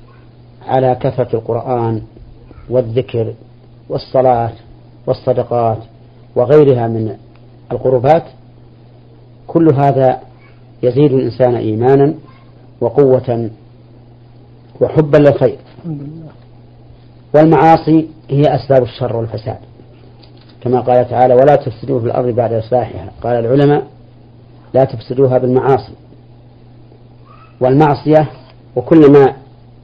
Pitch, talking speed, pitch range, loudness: 125 Hz, 80 wpm, 120-130 Hz, -13 LUFS